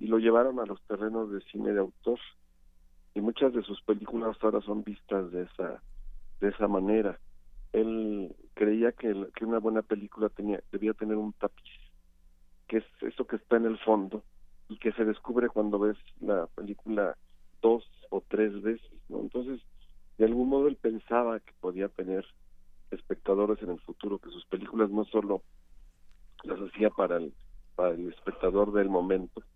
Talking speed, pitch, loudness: 170 wpm, 105 Hz, -31 LUFS